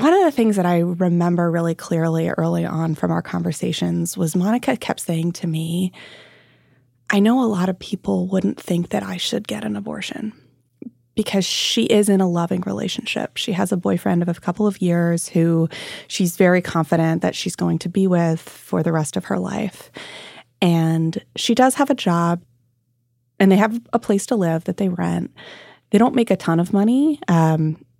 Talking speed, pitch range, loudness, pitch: 195 wpm, 165-205 Hz, -20 LUFS, 175 Hz